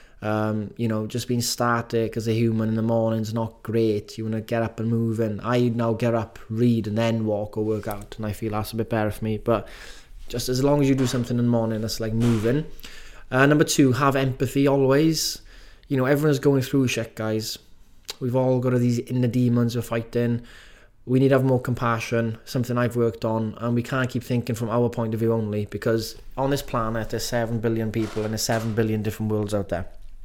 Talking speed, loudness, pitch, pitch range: 230 wpm, -24 LUFS, 115 Hz, 110-125 Hz